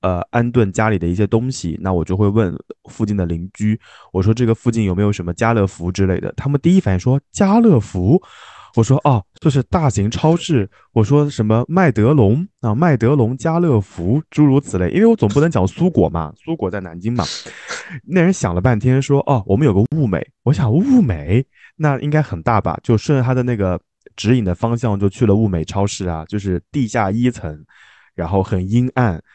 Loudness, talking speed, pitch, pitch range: -17 LUFS, 295 characters per minute, 115 Hz, 95-140 Hz